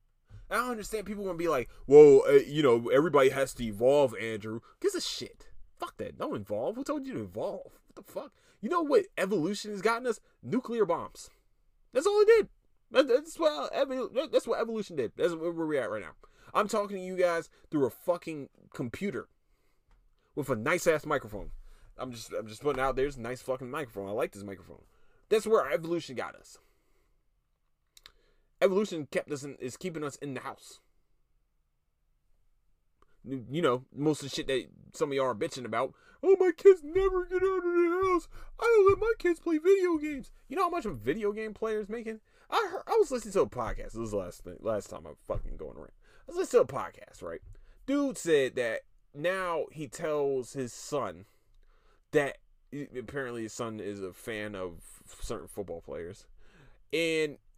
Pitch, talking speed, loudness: 180 Hz, 195 wpm, -29 LUFS